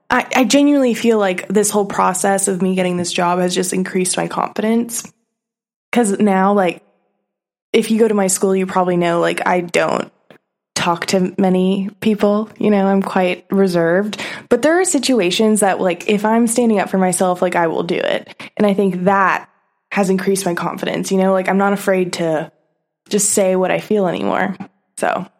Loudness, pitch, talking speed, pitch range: -16 LUFS, 195 Hz, 190 wpm, 185-215 Hz